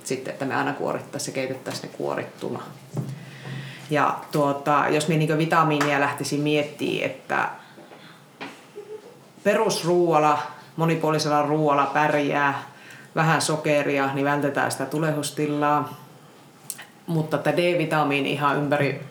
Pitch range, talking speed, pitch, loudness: 140-155 Hz, 105 wpm, 150 Hz, -23 LUFS